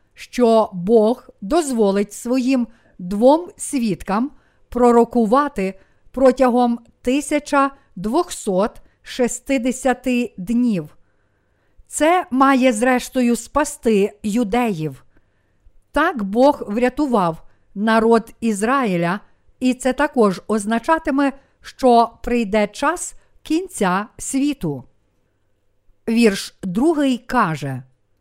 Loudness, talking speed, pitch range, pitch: -19 LUFS, 70 wpm, 195-260 Hz, 235 Hz